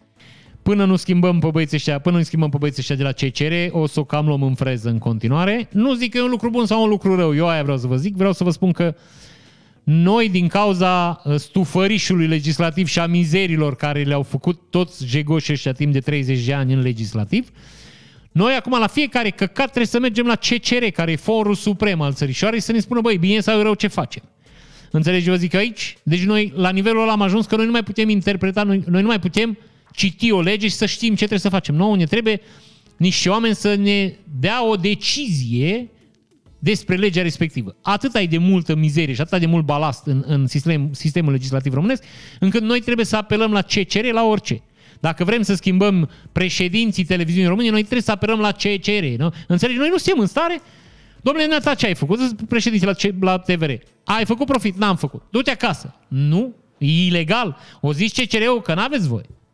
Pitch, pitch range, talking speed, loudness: 185 Hz, 155-215 Hz, 210 wpm, -18 LUFS